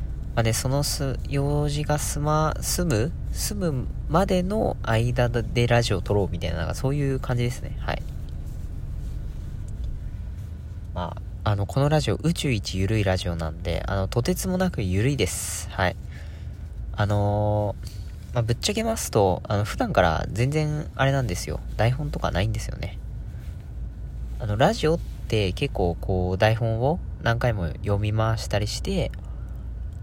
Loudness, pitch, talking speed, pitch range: -25 LUFS, 105 Hz, 280 characters per minute, 95-130 Hz